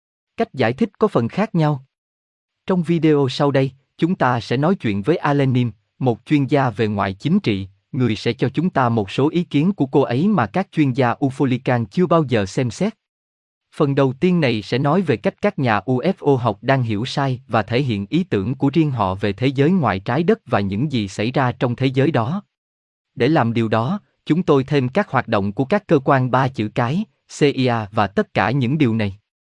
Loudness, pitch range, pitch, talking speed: -19 LUFS, 115-155 Hz, 135 Hz, 220 wpm